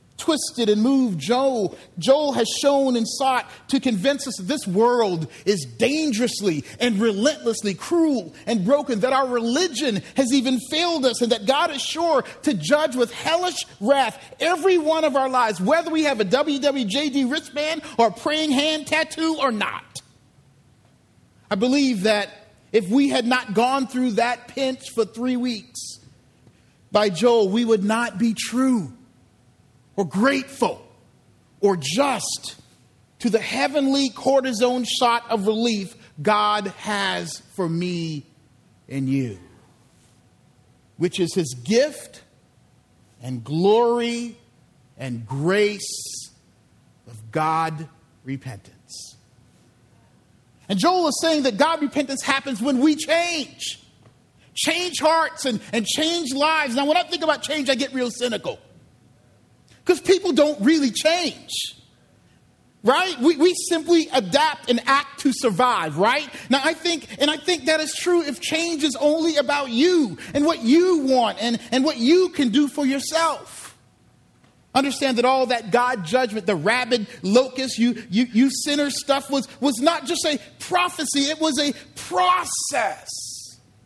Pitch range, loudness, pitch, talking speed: 205-295 Hz, -21 LUFS, 255 Hz, 140 wpm